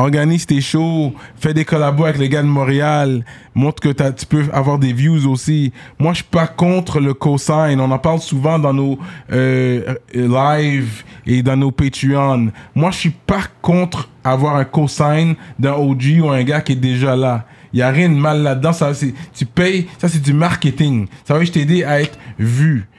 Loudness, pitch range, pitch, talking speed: -15 LUFS, 135-155 Hz, 145 Hz, 205 wpm